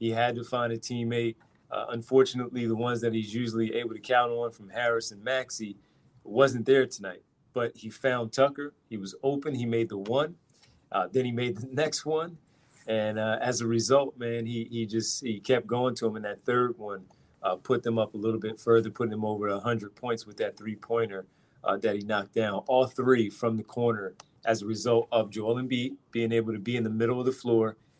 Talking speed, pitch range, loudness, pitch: 220 wpm, 110-125 Hz, -29 LUFS, 115 Hz